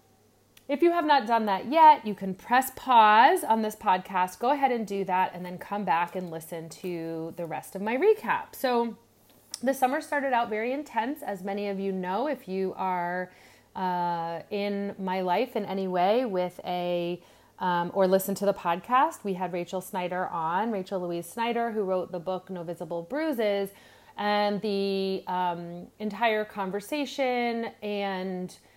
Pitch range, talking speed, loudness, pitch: 180-230 Hz, 170 wpm, -27 LUFS, 195 Hz